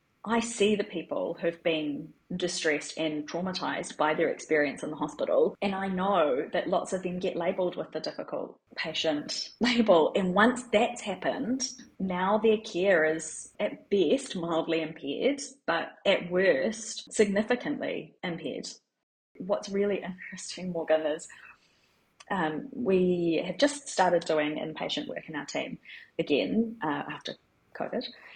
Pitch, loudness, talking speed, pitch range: 190 Hz, -29 LUFS, 140 wpm, 165-230 Hz